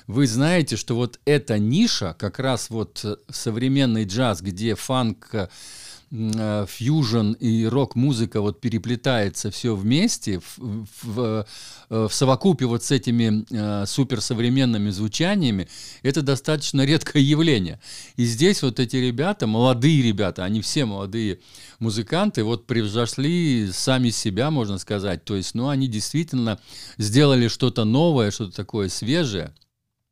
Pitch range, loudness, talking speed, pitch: 110-135 Hz, -22 LUFS, 120 wpm, 120 Hz